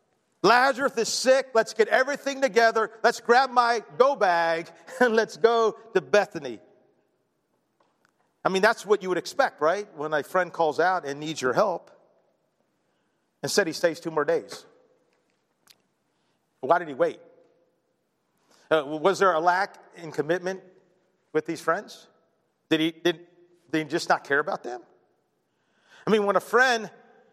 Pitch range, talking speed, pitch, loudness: 165-240 Hz, 155 wpm, 195 Hz, -24 LUFS